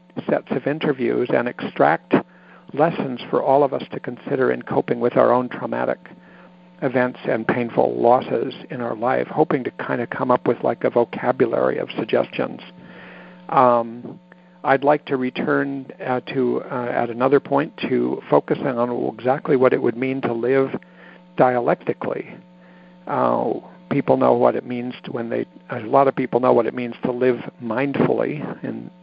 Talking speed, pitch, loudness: 165 wpm, 125 Hz, -21 LUFS